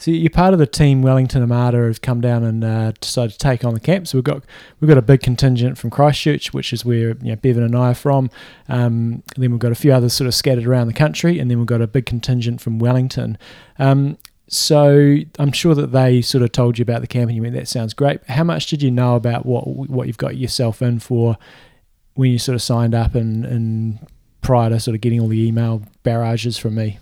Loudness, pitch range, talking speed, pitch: -17 LUFS, 115-135 Hz, 255 wpm, 125 Hz